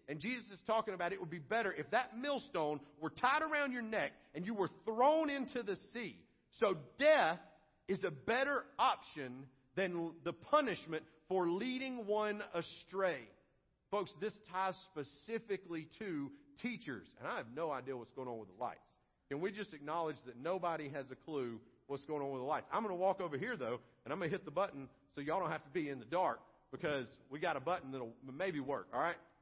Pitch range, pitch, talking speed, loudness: 150-215 Hz, 180 Hz, 210 wpm, -40 LUFS